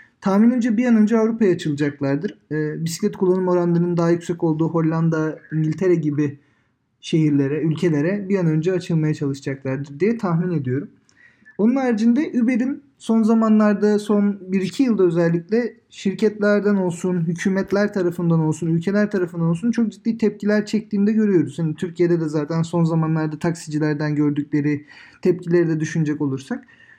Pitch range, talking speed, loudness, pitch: 155-210 Hz, 135 wpm, -20 LUFS, 175 Hz